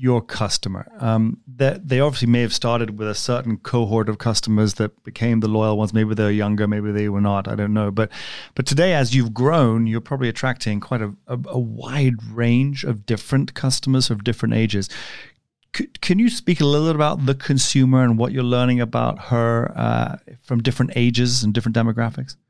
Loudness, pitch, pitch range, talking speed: -20 LUFS, 120 Hz, 110-130 Hz, 195 wpm